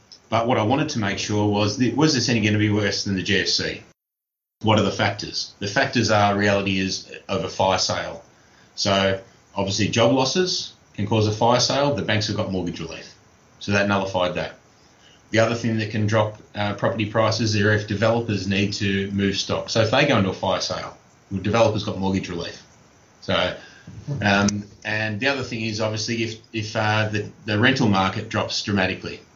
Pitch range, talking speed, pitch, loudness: 100-115 Hz, 190 wpm, 105 Hz, -22 LUFS